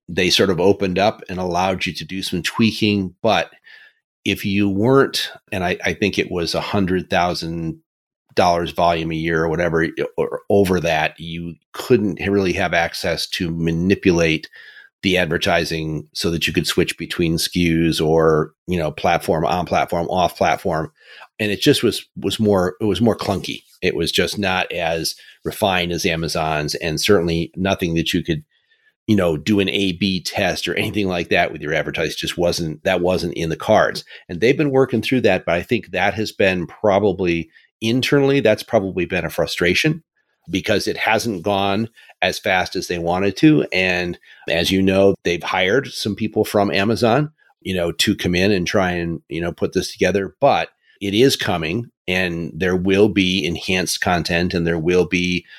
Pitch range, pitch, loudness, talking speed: 85-105 Hz, 95 Hz, -19 LUFS, 180 wpm